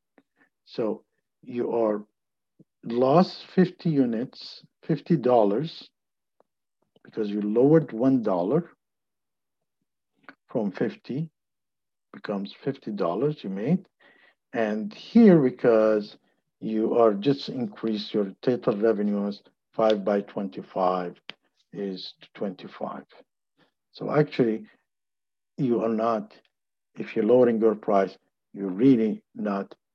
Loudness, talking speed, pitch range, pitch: -25 LUFS, 95 wpm, 105-140 Hz, 110 Hz